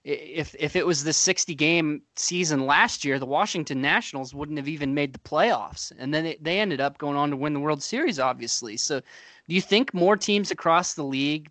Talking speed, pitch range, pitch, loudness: 220 wpm, 140-180 Hz, 150 Hz, -24 LUFS